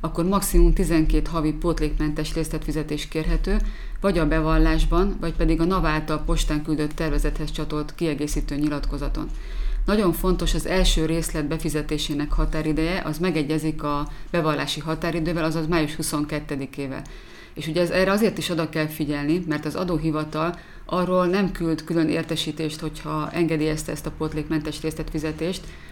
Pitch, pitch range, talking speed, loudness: 160 Hz, 155-170 Hz, 135 wpm, -24 LUFS